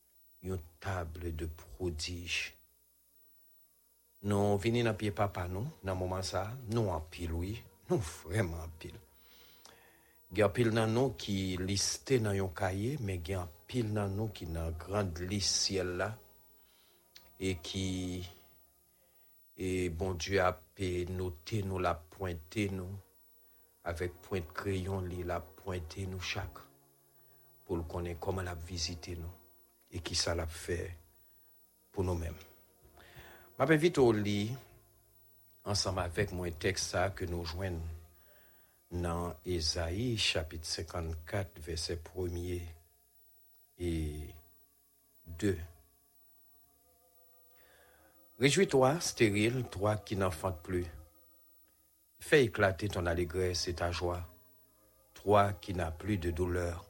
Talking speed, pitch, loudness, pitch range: 120 wpm, 90 Hz, -35 LUFS, 85-100 Hz